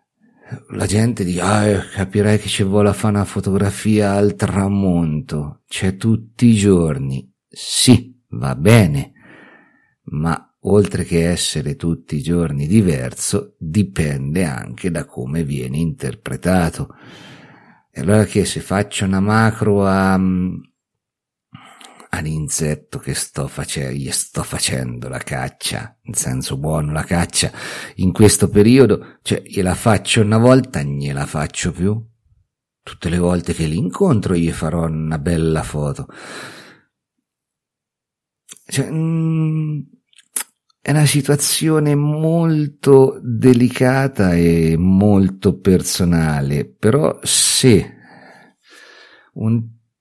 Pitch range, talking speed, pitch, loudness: 80-110 Hz, 110 wpm, 95 Hz, -17 LUFS